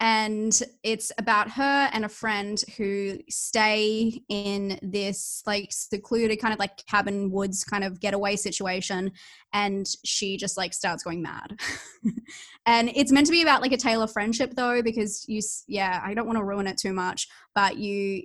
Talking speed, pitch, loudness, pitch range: 175 wpm, 210 Hz, -26 LUFS, 200-230 Hz